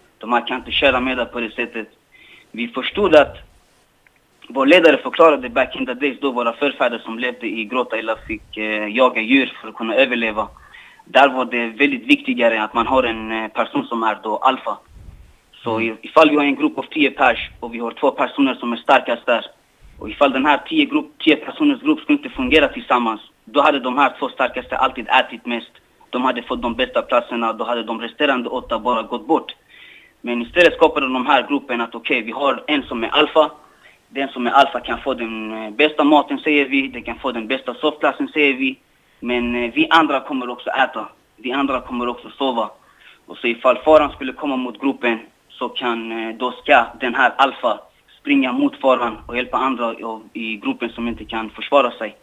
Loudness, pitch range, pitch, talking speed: -18 LUFS, 115-145 Hz, 125 Hz, 205 wpm